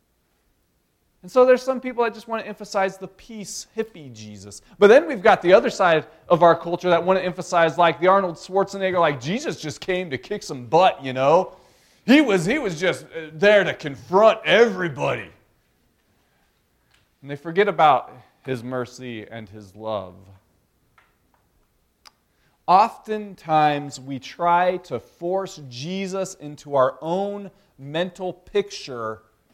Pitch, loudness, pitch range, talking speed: 170 Hz, -20 LUFS, 130-195 Hz, 145 wpm